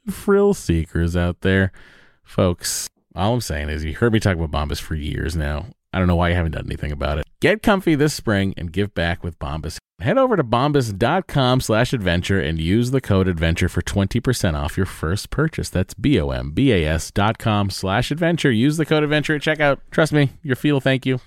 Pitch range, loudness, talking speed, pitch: 85-135 Hz, -20 LUFS, 190 wpm, 100 Hz